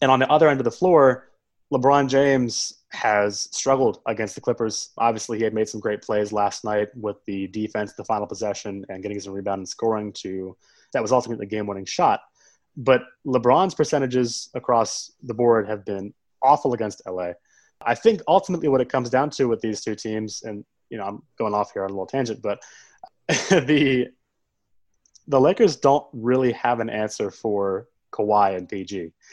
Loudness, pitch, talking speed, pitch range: -22 LUFS, 115 Hz, 185 wpm, 105-130 Hz